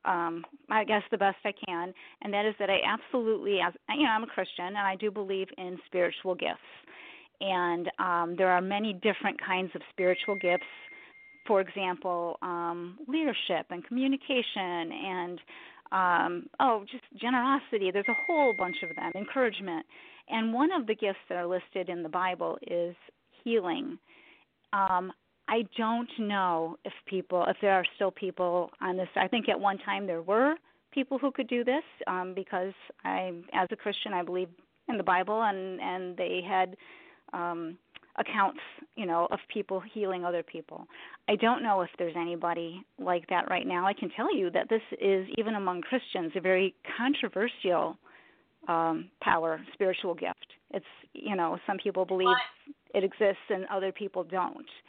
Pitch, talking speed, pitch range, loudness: 195 Hz, 170 wpm, 180-230 Hz, -30 LUFS